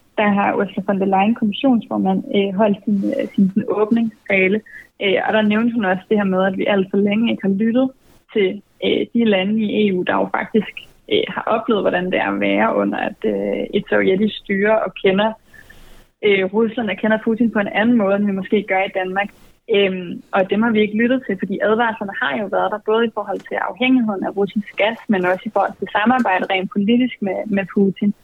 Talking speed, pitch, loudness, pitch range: 205 wpm, 205 Hz, -18 LUFS, 195-225 Hz